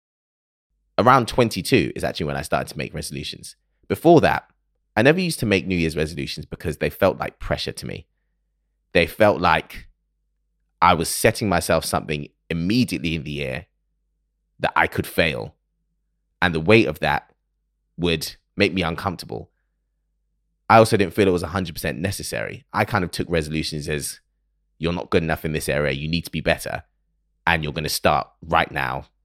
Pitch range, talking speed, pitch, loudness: 75-95 Hz, 175 wpm, 80 Hz, -21 LUFS